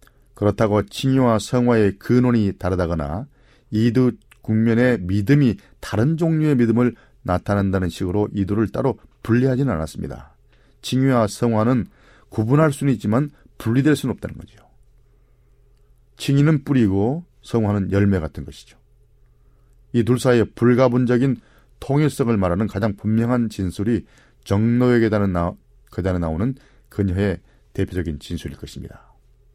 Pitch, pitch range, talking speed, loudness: 115 Hz, 100-125 Hz, 295 characters per minute, -20 LUFS